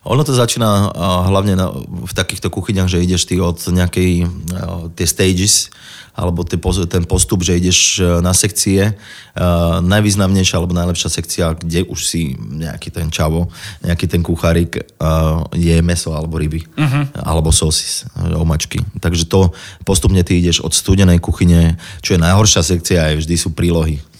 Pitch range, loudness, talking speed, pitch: 85-95 Hz, -15 LUFS, 140 wpm, 90 Hz